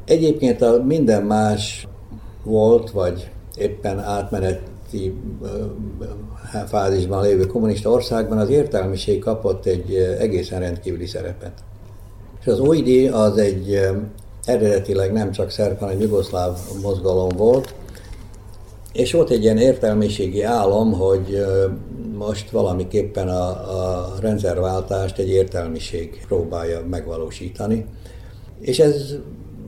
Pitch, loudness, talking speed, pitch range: 100 Hz, -20 LUFS, 100 wpm, 95-110 Hz